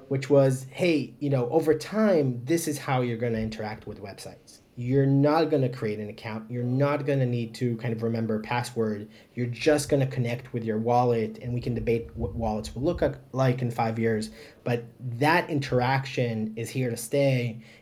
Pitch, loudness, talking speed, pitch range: 120 Hz, -27 LUFS, 200 wpm, 115-135 Hz